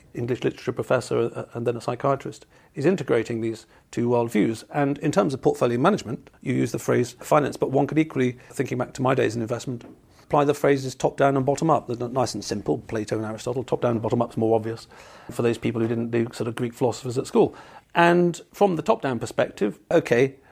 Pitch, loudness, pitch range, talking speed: 125 Hz, -24 LUFS, 115-140 Hz, 210 wpm